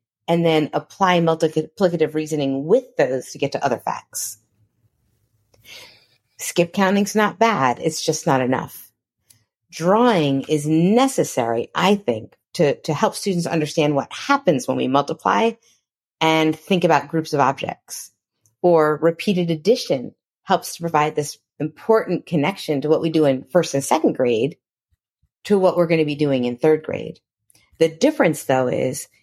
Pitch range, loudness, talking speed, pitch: 135-175 Hz, -20 LUFS, 150 wpm, 155 Hz